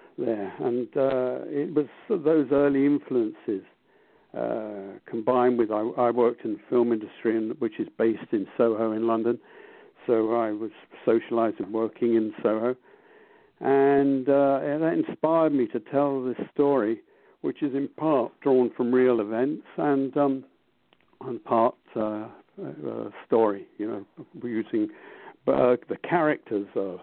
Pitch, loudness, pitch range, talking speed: 135 Hz, -26 LUFS, 115-155 Hz, 145 wpm